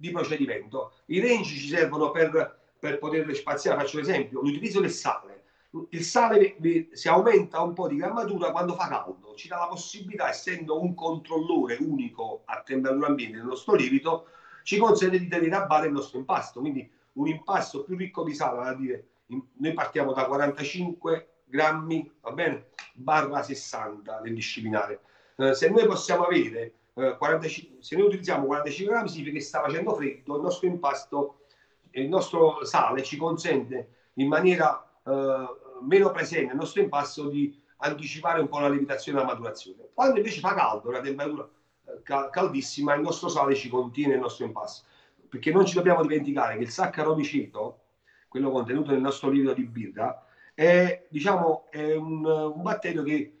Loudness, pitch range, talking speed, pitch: -27 LUFS, 140-180 Hz, 165 wpm, 155 Hz